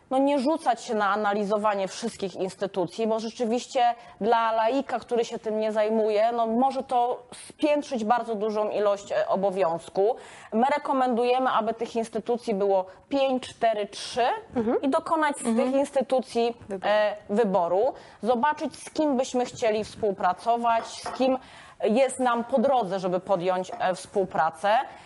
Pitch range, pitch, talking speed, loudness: 205-260 Hz, 230 Hz, 130 wpm, -26 LUFS